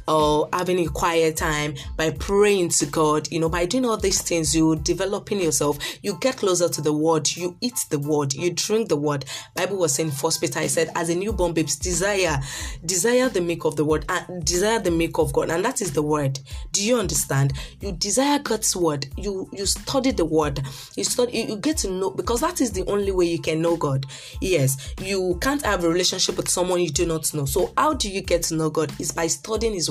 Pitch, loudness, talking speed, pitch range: 170 Hz, -22 LUFS, 235 wpm, 155-195 Hz